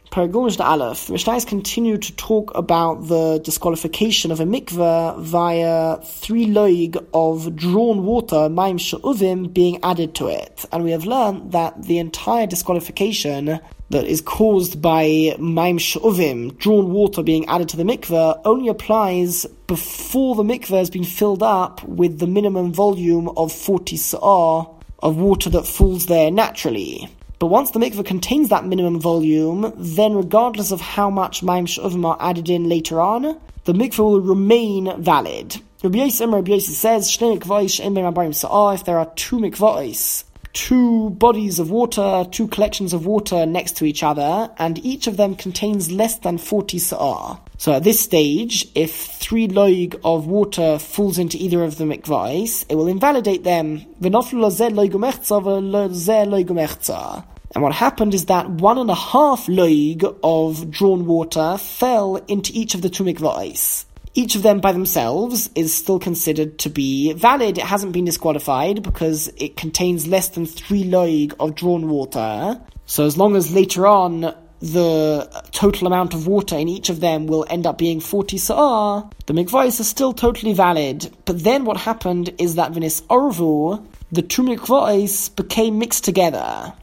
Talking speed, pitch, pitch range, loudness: 150 wpm, 185 Hz, 165-210 Hz, -18 LUFS